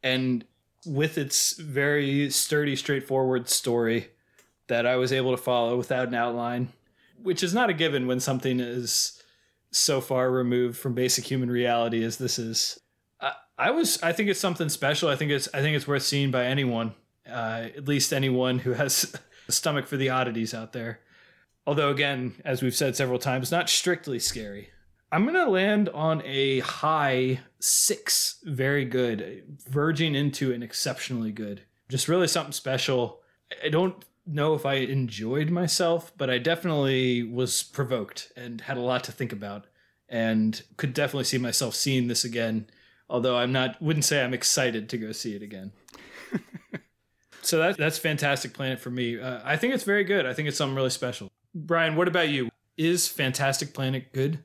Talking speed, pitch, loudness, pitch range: 175 wpm, 130 Hz, -26 LUFS, 120-150 Hz